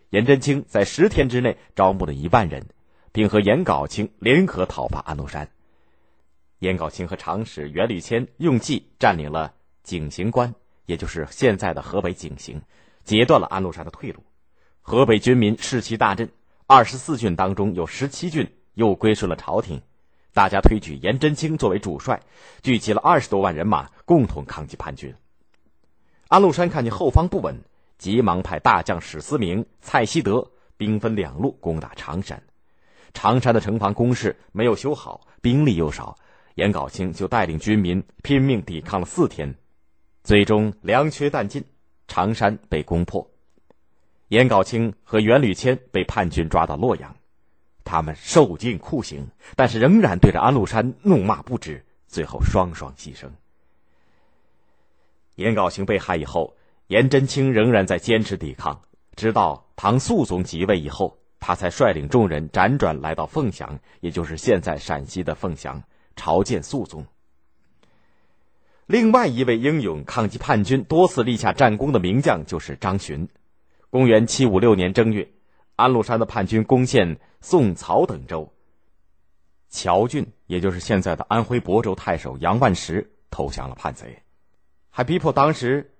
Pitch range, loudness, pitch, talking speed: 80-115 Hz, -21 LUFS, 95 Hz, 235 characters per minute